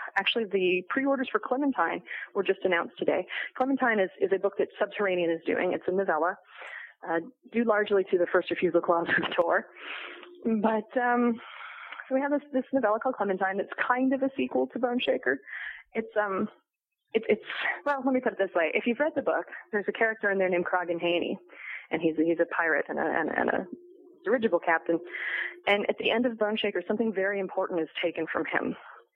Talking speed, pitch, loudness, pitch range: 205 wpm, 210 Hz, -28 LUFS, 185-255 Hz